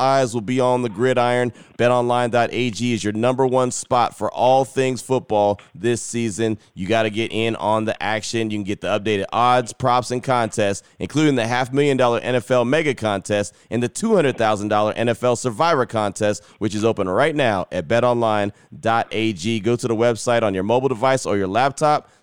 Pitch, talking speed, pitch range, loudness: 120 Hz, 190 wpm, 110-125 Hz, -20 LUFS